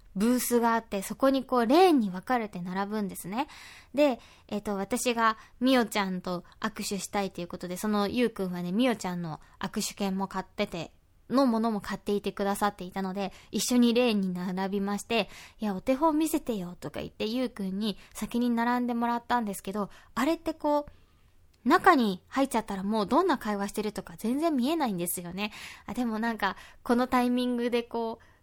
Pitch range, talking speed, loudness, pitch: 195-245 Hz, 395 characters per minute, -29 LUFS, 215 Hz